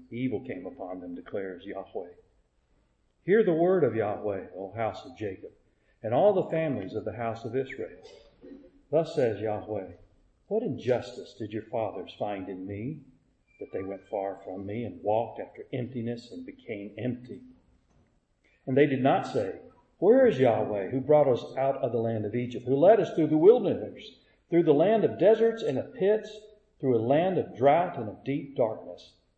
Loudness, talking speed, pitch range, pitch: -27 LUFS, 180 wpm, 100-150 Hz, 120 Hz